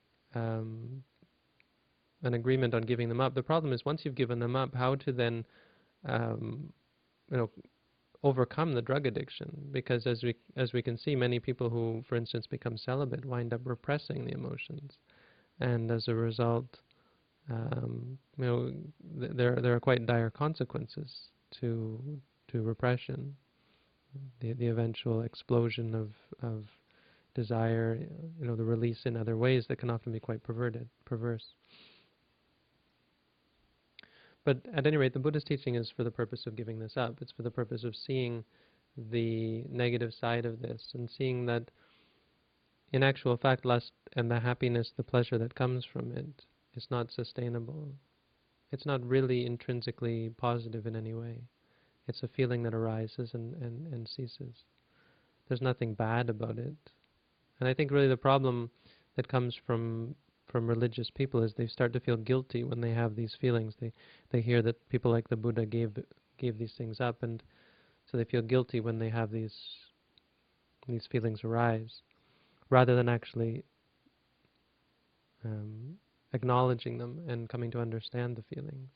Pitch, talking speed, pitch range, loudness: 120 Hz, 160 wpm, 115-130 Hz, -34 LUFS